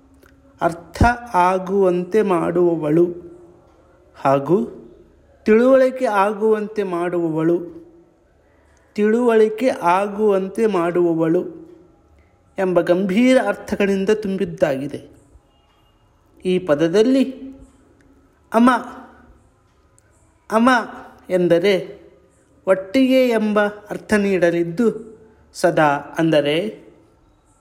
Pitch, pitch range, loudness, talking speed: 190 Hz, 170-220 Hz, -18 LUFS, 55 wpm